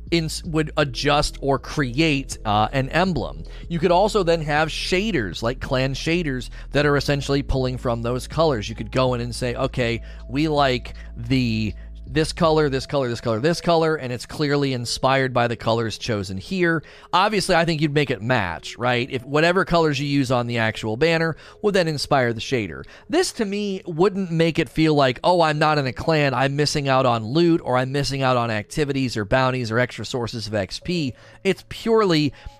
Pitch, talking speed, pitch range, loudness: 135 Hz, 200 wpm, 120-160 Hz, -21 LUFS